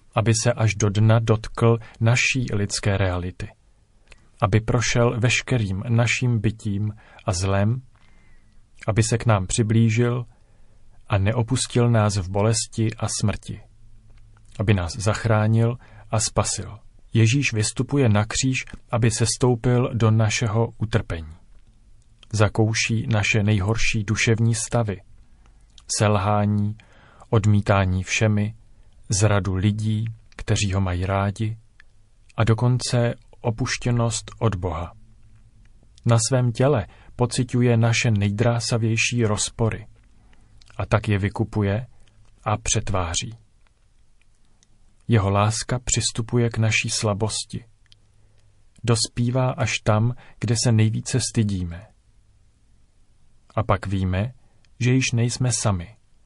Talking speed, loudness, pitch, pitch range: 100 wpm, -22 LUFS, 110 Hz, 105-115 Hz